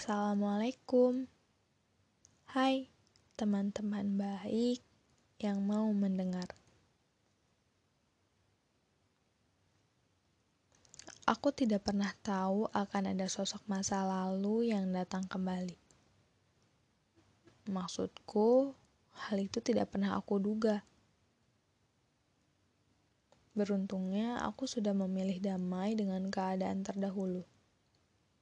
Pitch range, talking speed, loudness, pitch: 185-210 Hz, 70 wpm, -36 LUFS, 200 Hz